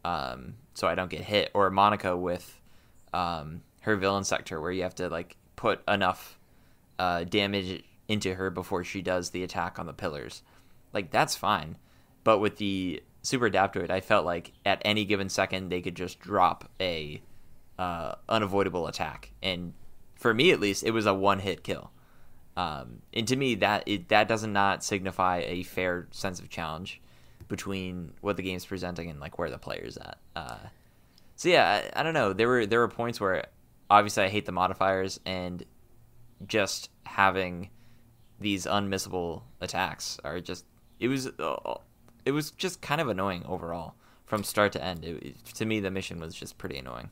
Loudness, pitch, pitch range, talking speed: -29 LUFS, 95 Hz, 90-105 Hz, 180 wpm